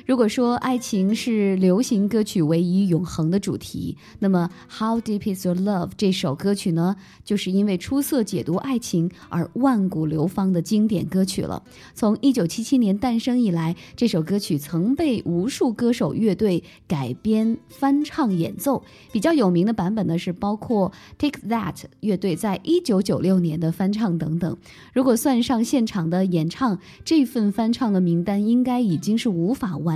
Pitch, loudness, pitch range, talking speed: 200 Hz, -22 LUFS, 180-235 Hz, 275 characters per minute